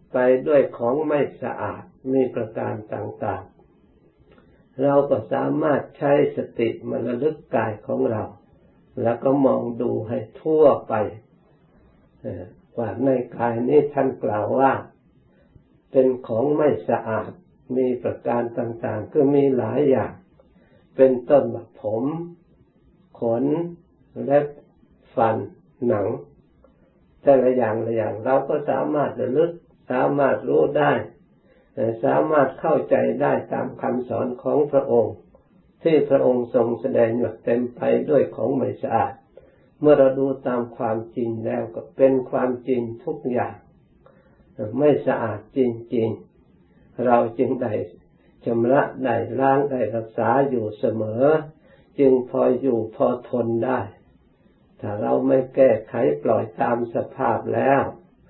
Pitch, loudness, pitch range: 130 Hz, -22 LUFS, 115-135 Hz